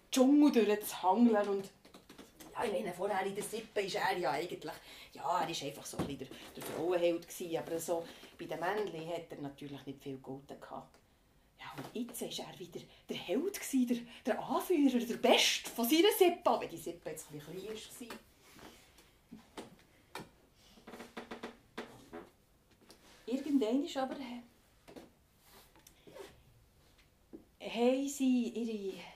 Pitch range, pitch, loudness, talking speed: 175-255 Hz, 215 Hz, -34 LUFS, 135 wpm